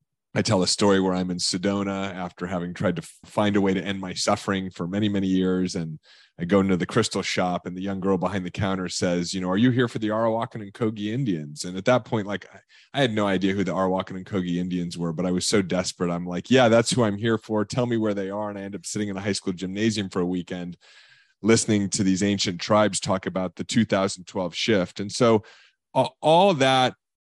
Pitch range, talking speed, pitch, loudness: 90-105 Hz, 250 wpm, 95 Hz, -24 LUFS